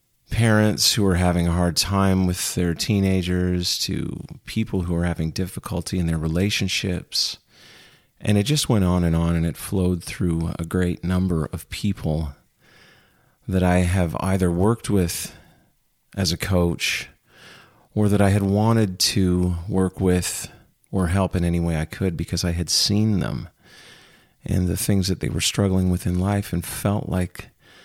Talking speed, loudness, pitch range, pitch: 165 wpm, -22 LUFS, 85-100 Hz, 90 Hz